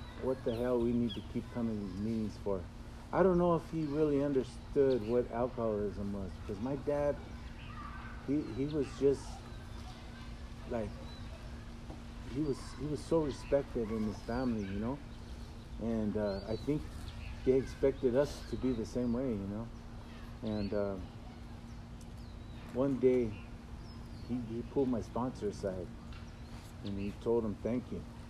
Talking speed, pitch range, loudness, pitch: 145 wpm, 105-125 Hz, -36 LUFS, 115 Hz